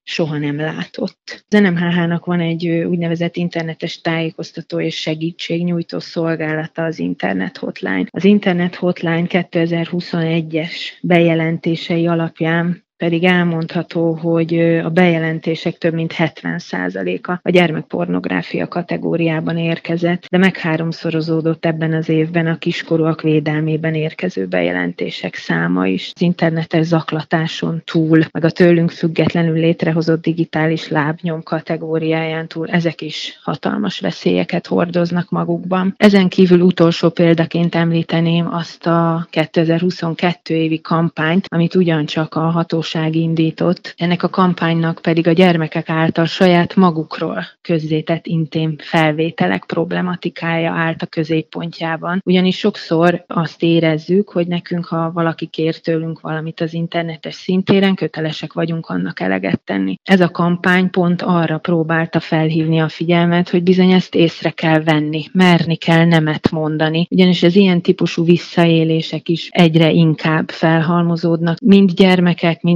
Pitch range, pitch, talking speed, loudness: 160-175 Hz, 165 Hz, 120 wpm, -16 LUFS